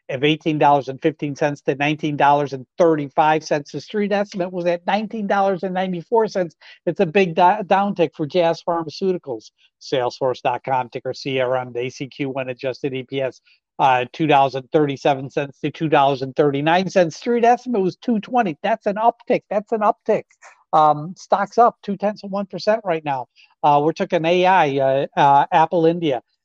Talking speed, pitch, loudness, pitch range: 130 wpm, 160 Hz, -20 LUFS, 140-195 Hz